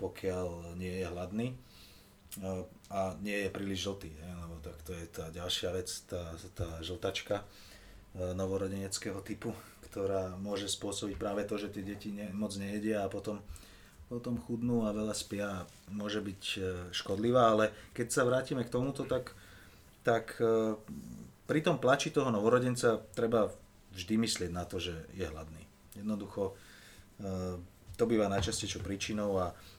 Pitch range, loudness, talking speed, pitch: 90-105 Hz, -35 LUFS, 135 wpm, 100 Hz